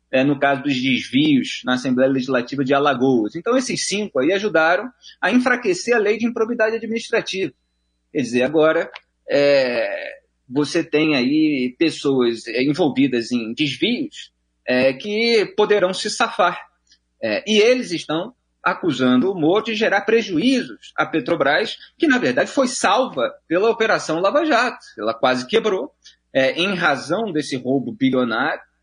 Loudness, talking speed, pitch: -19 LUFS, 140 wpm, 175 Hz